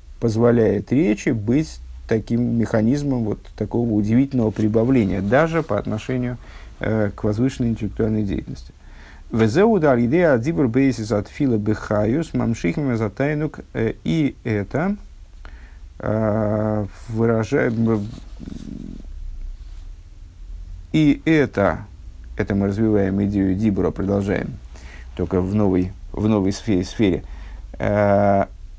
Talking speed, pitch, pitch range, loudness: 100 wpm, 105 Hz, 95-120 Hz, -20 LUFS